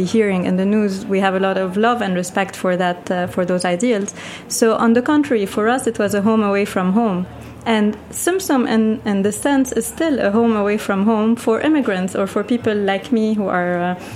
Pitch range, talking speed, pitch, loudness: 195-230 Hz, 235 wpm, 210 Hz, -18 LUFS